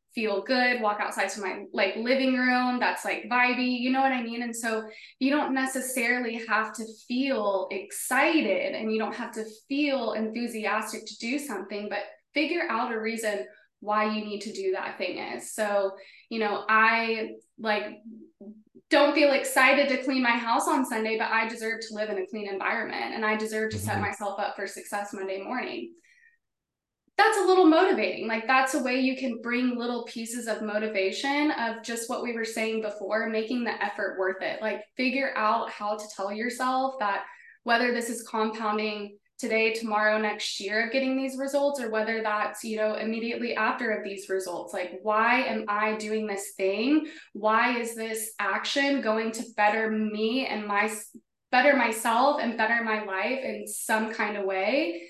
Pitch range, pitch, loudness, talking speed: 210-250 Hz, 220 Hz, -27 LUFS, 185 wpm